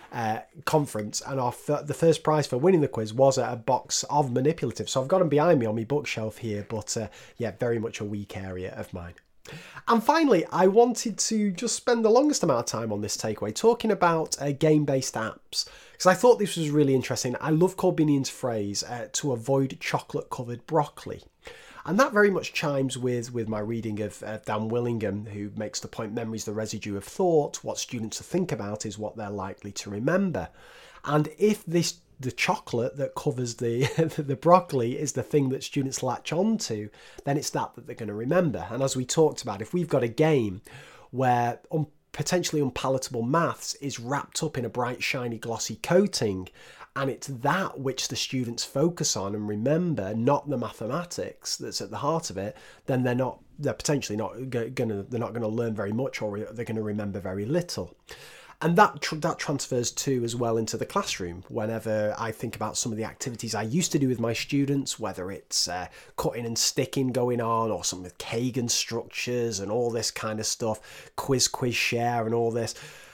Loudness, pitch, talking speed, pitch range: -27 LUFS, 125 Hz, 205 wpm, 110-150 Hz